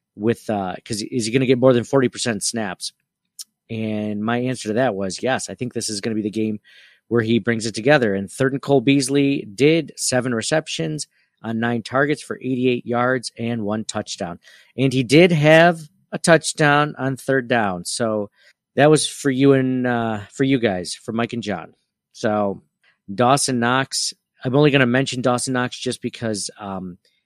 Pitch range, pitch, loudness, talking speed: 110-140 Hz, 125 Hz, -20 LUFS, 190 wpm